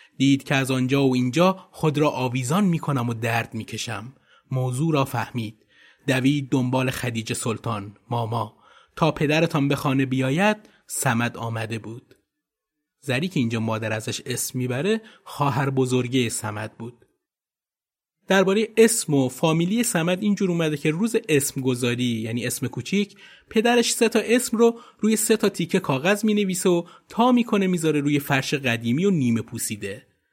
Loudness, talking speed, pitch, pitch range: -23 LUFS, 155 wpm, 135 Hz, 120-185 Hz